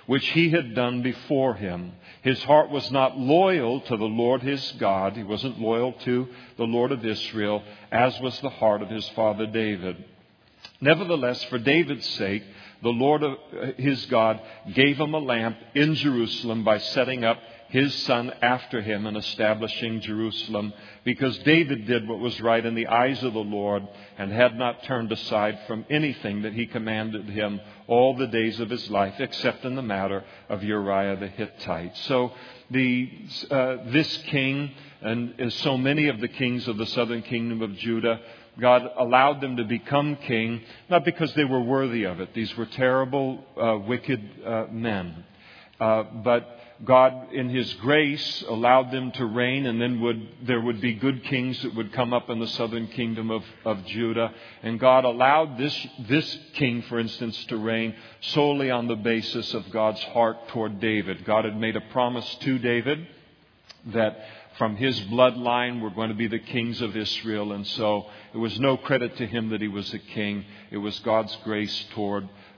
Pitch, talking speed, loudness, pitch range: 115 Hz, 180 wpm, -25 LUFS, 110-130 Hz